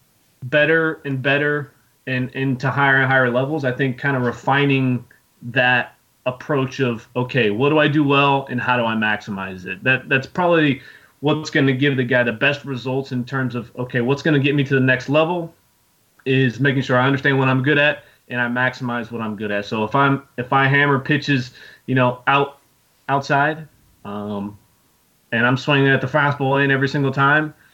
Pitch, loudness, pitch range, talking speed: 135 Hz, -19 LUFS, 125-140 Hz, 200 wpm